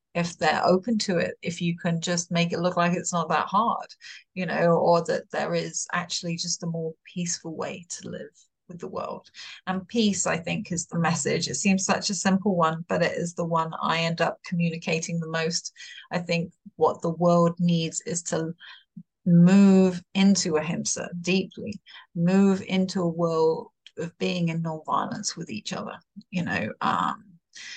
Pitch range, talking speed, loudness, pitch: 170-190 Hz, 180 wpm, -25 LUFS, 175 Hz